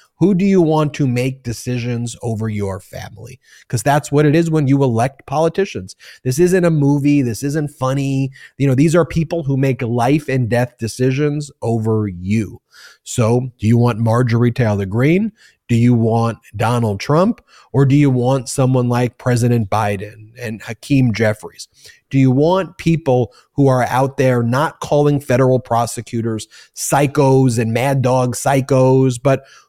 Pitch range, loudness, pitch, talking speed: 115-145 Hz, -16 LUFS, 130 Hz, 160 wpm